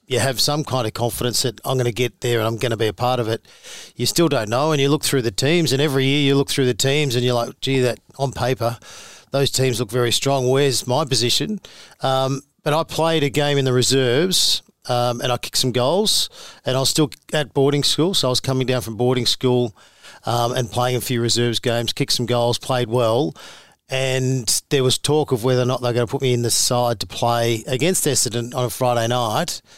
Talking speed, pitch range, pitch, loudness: 240 wpm, 120-140 Hz, 125 Hz, -19 LUFS